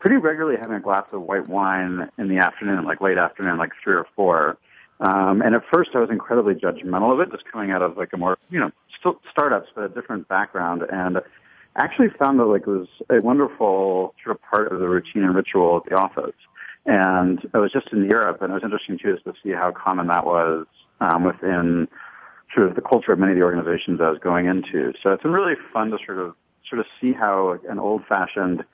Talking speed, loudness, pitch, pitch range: 230 wpm, -21 LUFS, 95 Hz, 90-95 Hz